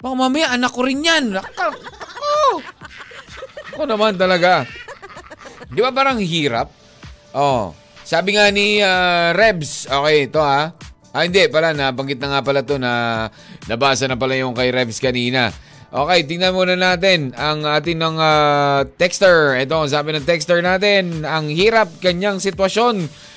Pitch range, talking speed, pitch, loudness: 140-205 Hz, 150 wpm, 170 Hz, -16 LUFS